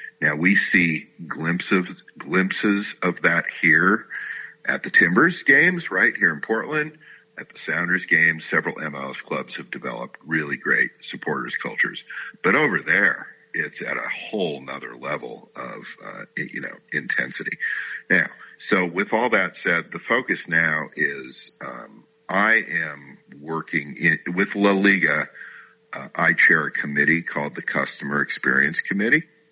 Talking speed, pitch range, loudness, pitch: 145 wpm, 80-110 Hz, -21 LUFS, 100 Hz